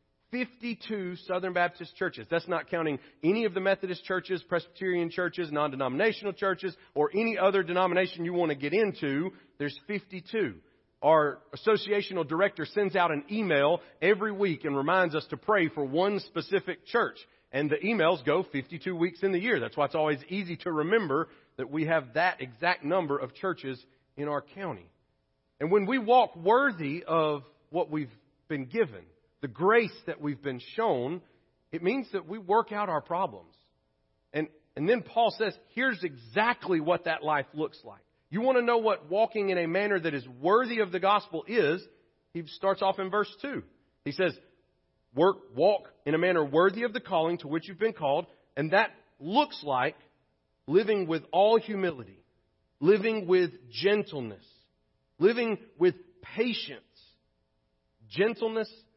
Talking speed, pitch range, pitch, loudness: 165 wpm, 155-205 Hz, 180 Hz, -29 LUFS